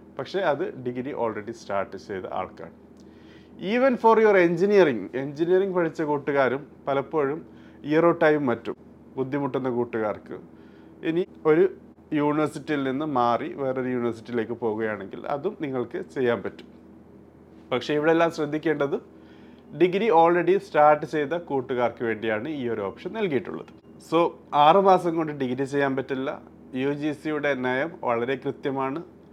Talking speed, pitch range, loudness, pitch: 115 wpm, 125-165 Hz, -24 LUFS, 145 Hz